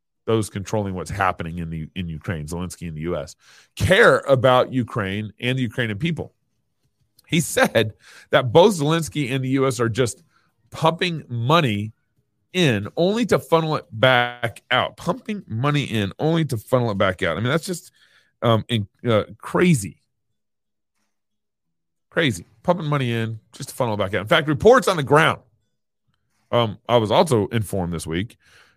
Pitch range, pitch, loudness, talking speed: 100-135 Hz, 115 Hz, -21 LUFS, 165 wpm